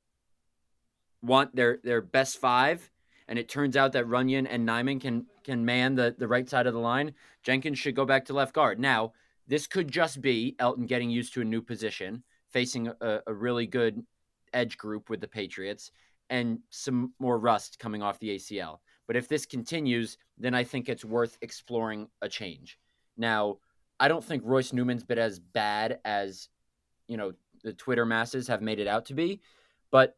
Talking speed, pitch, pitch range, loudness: 185 wpm, 120 Hz, 110-130 Hz, -29 LUFS